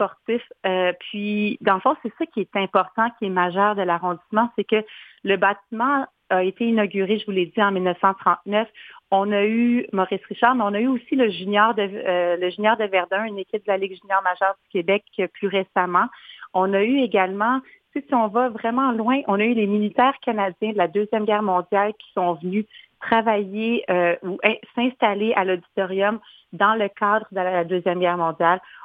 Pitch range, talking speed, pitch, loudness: 190-225 Hz, 200 wpm, 205 Hz, -22 LUFS